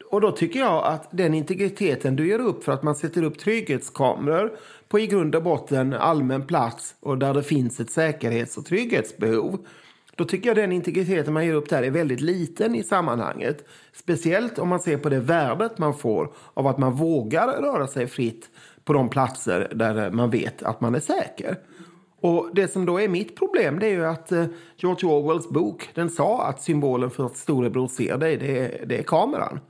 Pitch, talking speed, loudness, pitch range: 160 Hz, 200 wpm, -24 LUFS, 135-180 Hz